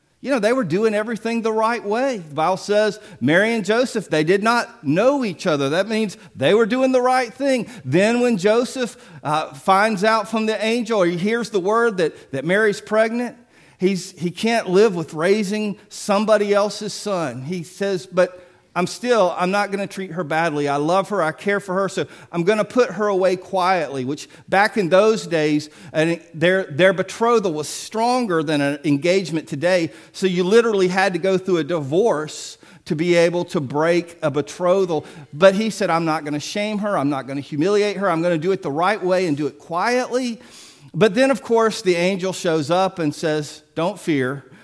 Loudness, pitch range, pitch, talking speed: -20 LUFS, 165-220 Hz, 190 Hz, 205 wpm